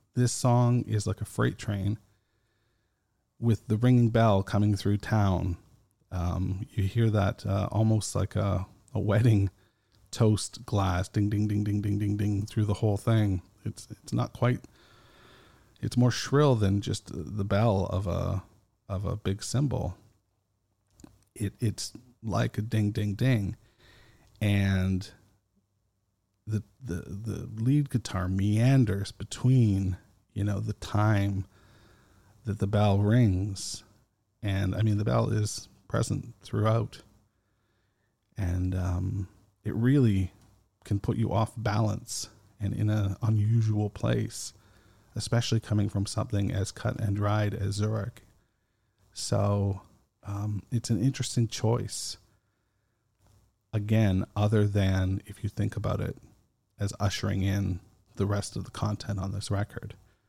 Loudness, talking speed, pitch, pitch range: -29 LUFS, 135 wpm, 105 Hz, 100-115 Hz